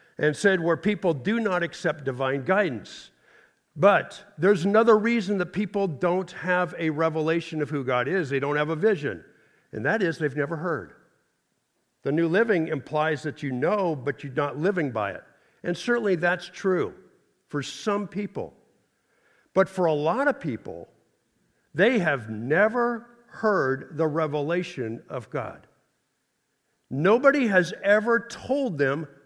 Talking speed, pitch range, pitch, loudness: 150 wpm, 150-205 Hz, 170 Hz, -25 LUFS